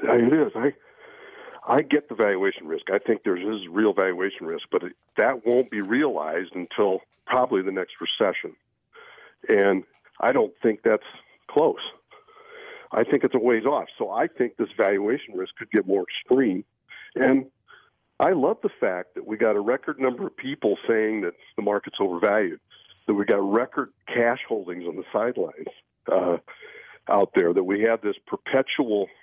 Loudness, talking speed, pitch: -24 LUFS, 175 wpm, 390 Hz